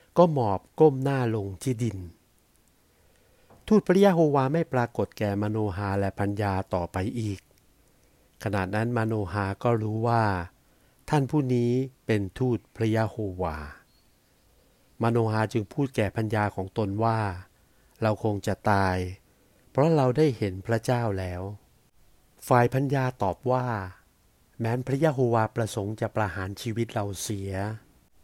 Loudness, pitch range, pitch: -27 LUFS, 100-120 Hz, 110 Hz